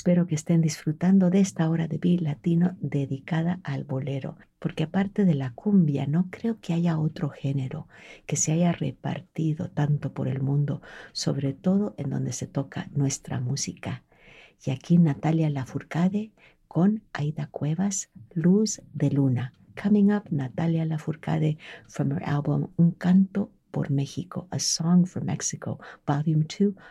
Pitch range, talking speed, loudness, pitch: 140-175 Hz, 150 wpm, -26 LUFS, 160 Hz